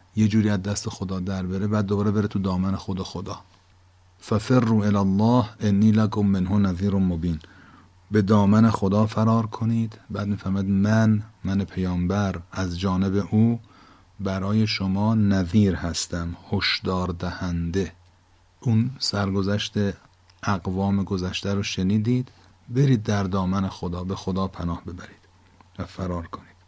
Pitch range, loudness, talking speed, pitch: 90-105 Hz, -24 LUFS, 130 wpm, 100 Hz